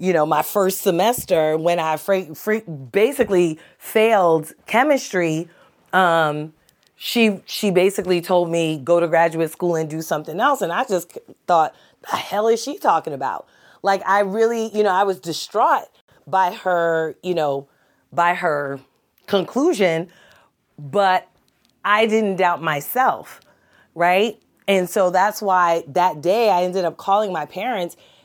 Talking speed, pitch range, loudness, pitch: 145 wpm, 165-200 Hz, -19 LUFS, 180 Hz